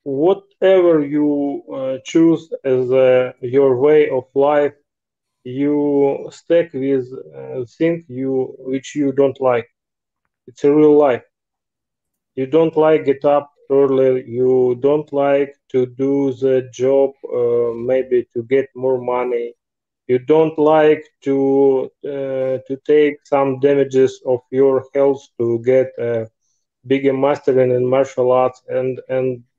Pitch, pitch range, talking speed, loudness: 135 Hz, 130-145 Hz, 130 wpm, -17 LUFS